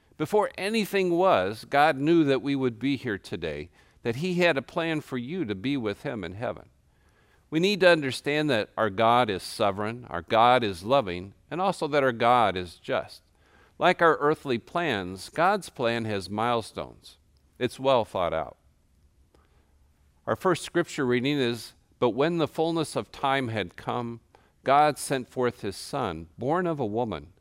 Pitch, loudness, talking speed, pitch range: 125 Hz, -26 LUFS, 170 wpm, 100-150 Hz